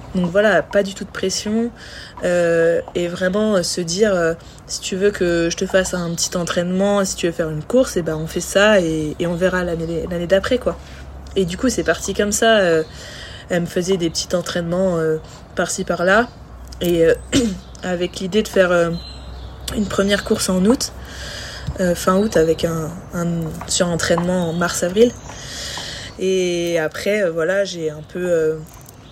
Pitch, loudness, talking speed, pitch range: 180 Hz, -19 LUFS, 185 wpm, 170-195 Hz